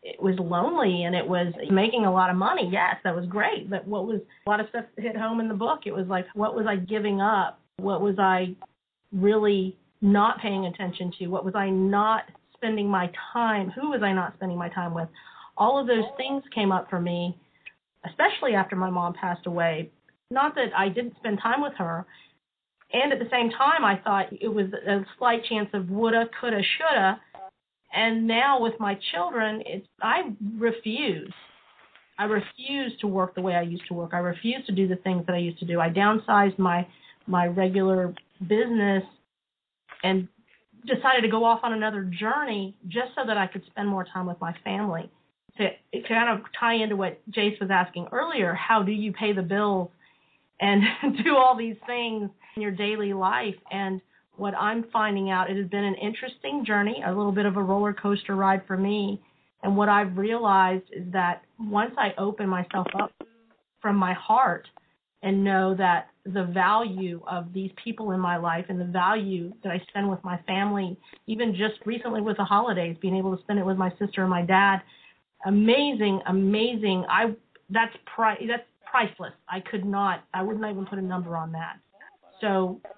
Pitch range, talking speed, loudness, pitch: 185-220 Hz, 195 wpm, -26 LUFS, 200 Hz